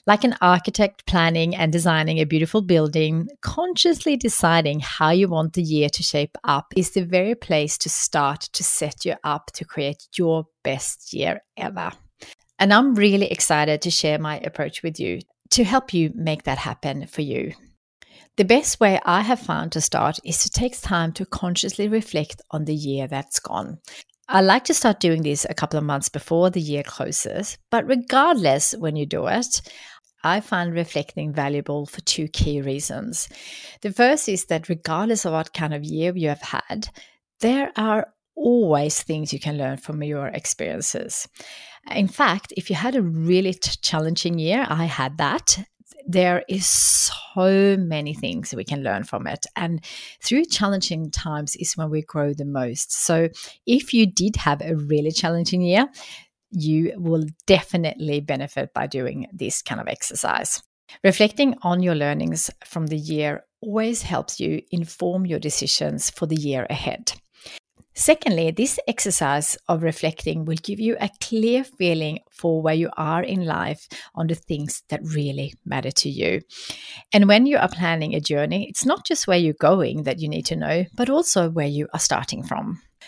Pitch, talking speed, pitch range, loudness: 165 Hz, 175 wpm, 150-200 Hz, -21 LUFS